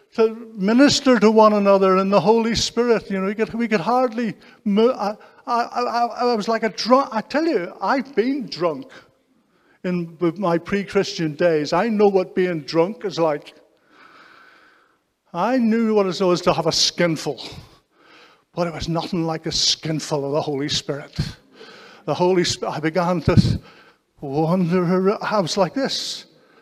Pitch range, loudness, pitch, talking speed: 165-225 Hz, -20 LUFS, 195 Hz, 165 wpm